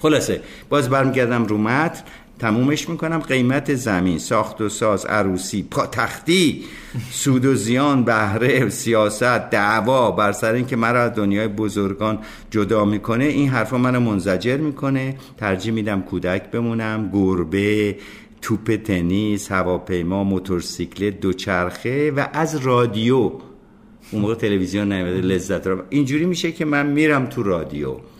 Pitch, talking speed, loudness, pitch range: 110 Hz, 130 wpm, -20 LUFS, 100-130 Hz